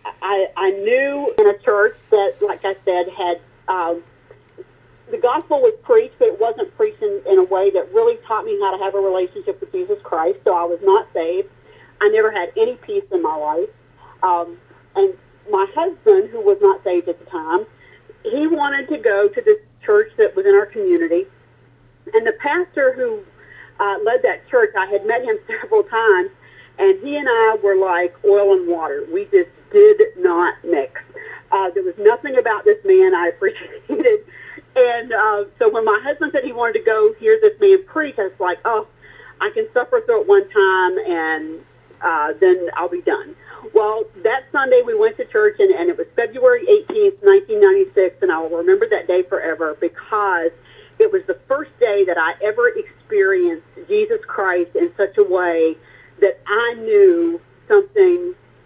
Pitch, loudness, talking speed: 390 Hz, -17 LUFS, 185 wpm